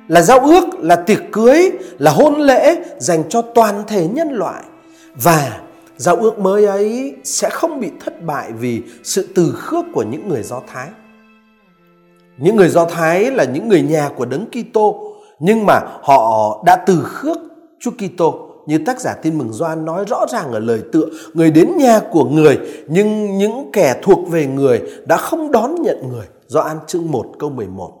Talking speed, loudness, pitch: 185 wpm, -14 LUFS, 210 Hz